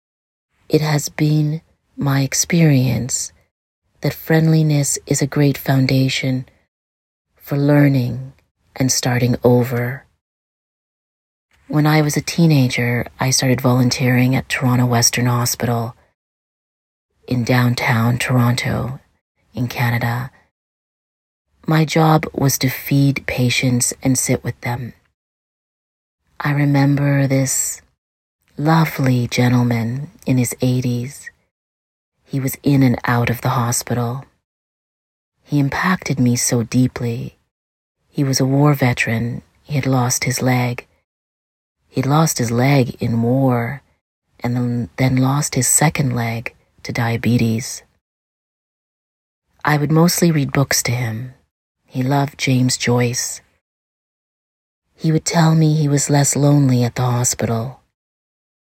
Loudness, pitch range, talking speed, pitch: -17 LUFS, 120-140 Hz, 115 wpm, 125 Hz